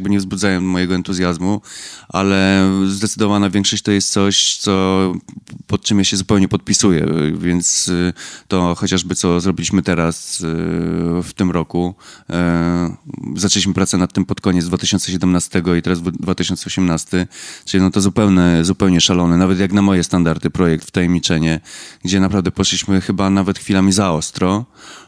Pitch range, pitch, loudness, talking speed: 90-100 Hz, 95 Hz, -16 LUFS, 140 wpm